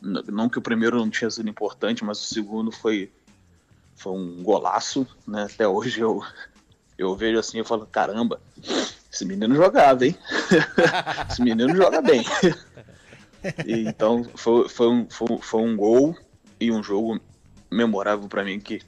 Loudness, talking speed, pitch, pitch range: -22 LUFS, 155 wpm, 110 Hz, 105-115 Hz